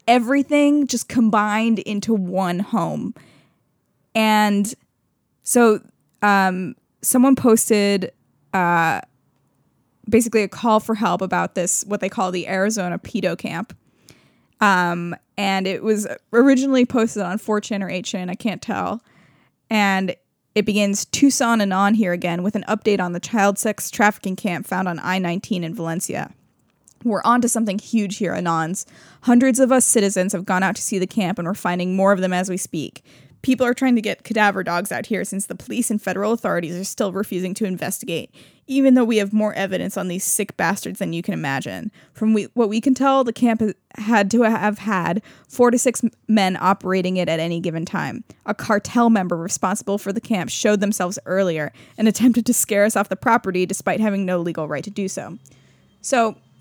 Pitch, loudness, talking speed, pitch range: 205 Hz, -20 LUFS, 180 wpm, 185-225 Hz